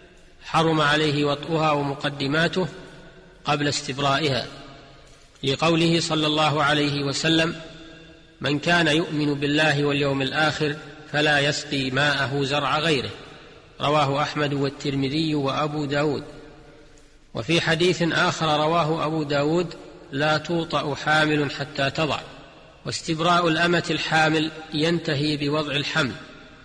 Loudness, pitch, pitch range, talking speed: -22 LUFS, 150 Hz, 145-160 Hz, 100 wpm